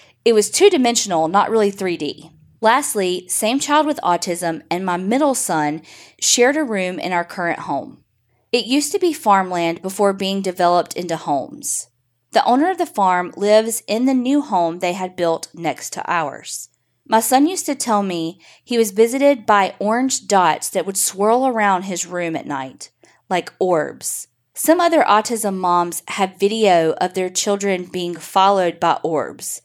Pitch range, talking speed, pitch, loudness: 175-235 Hz, 170 wpm, 195 Hz, -18 LUFS